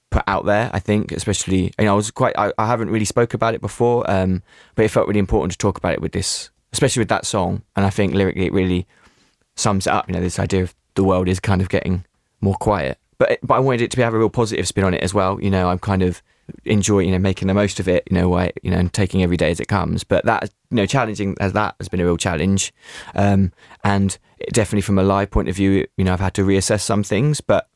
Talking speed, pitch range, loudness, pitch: 275 wpm, 95-105 Hz, -19 LUFS, 100 Hz